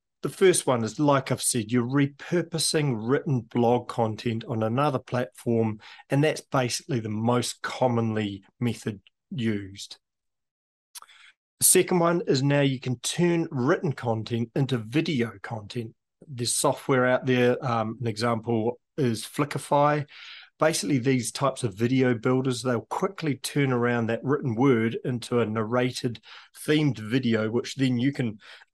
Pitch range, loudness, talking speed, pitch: 115-140 Hz, -25 LUFS, 140 wpm, 125 Hz